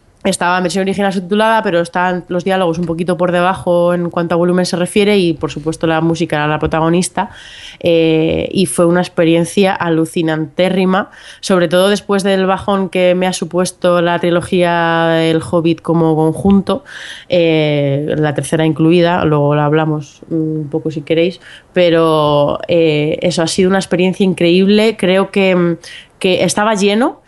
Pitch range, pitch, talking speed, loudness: 165-185 Hz, 175 Hz, 160 wpm, -13 LUFS